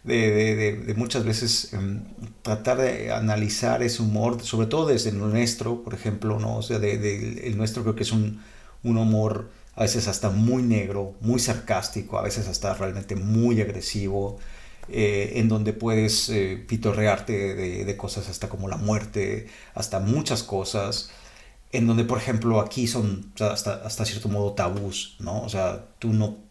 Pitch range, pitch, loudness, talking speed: 100-115 Hz, 110 Hz, -25 LUFS, 180 wpm